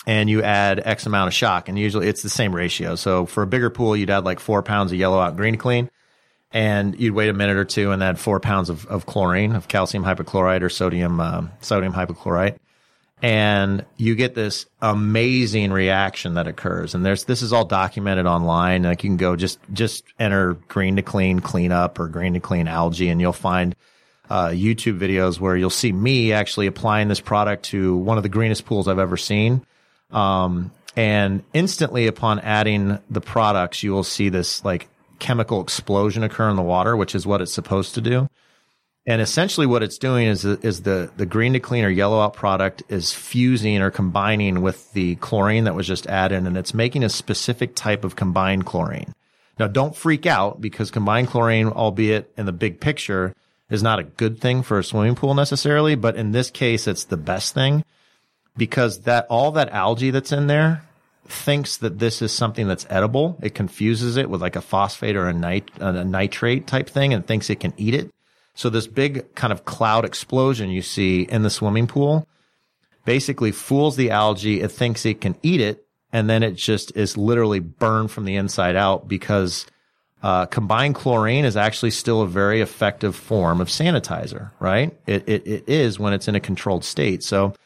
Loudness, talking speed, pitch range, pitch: -20 LUFS, 200 wpm, 95-115 Hz, 105 Hz